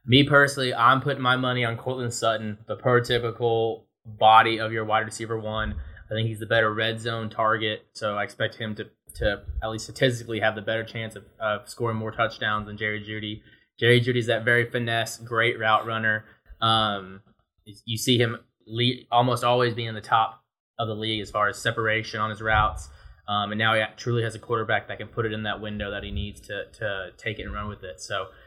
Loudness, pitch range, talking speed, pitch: -25 LUFS, 105-115 Hz, 215 wpm, 110 Hz